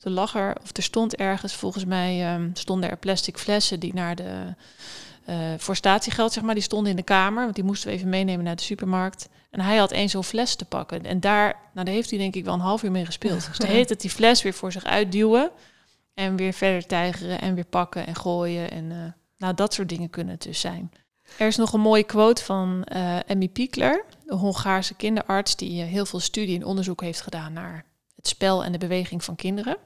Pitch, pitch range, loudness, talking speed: 190 Hz, 180-210 Hz, -24 LUFS, 230 wpm